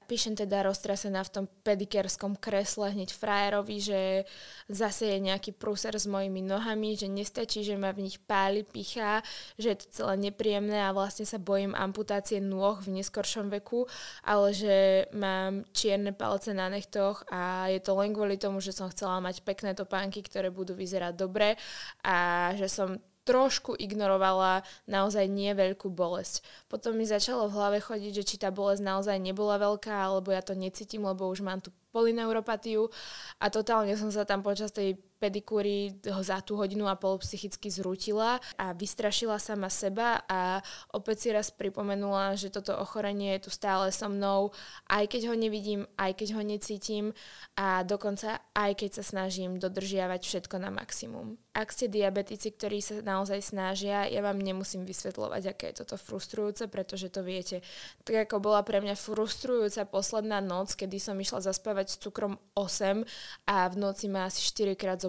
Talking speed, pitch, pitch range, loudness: 170 wpm, 200 Hz, 195-210 Hz, -31 LUFS